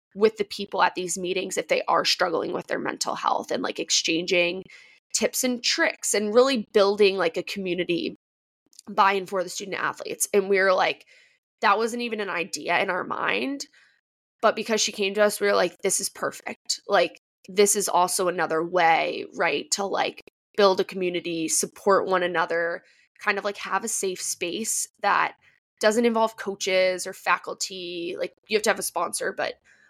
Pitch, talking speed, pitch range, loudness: 195 Hz, 185 wpm, 180-215 Hz, -24 LUFS